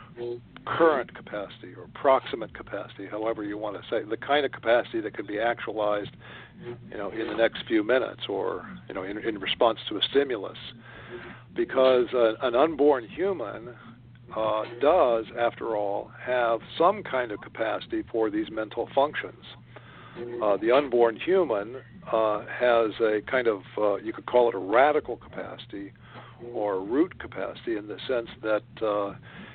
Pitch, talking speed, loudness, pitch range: 120 Hz, 155 wpm, -27 LUFS, 110-130 Hz